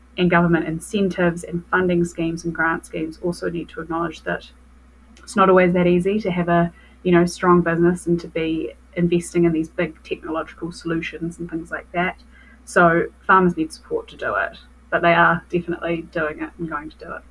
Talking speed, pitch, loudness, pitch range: 200 wpm, 170 Hz, -21 LUFS, 165-175 Hz